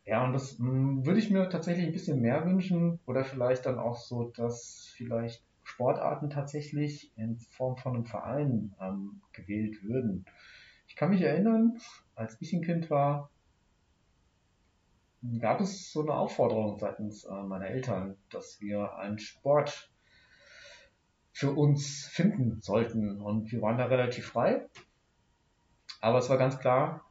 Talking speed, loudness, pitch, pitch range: 140 wpm, -31 LUFS, 125 Hz, 110-145 Hz